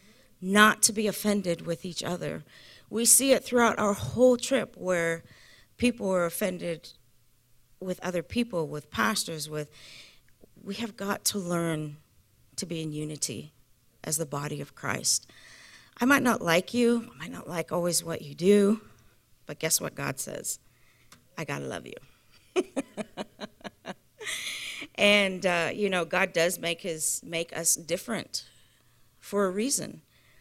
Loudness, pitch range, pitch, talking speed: -27 LUFS, 150-205 Hz, 175 Hz, 145 wpm